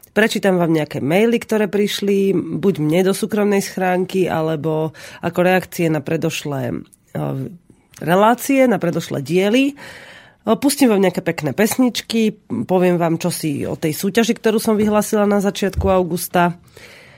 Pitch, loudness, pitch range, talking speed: 190 Hz, -18 LUFS, 170-215 Hz, 130 wpm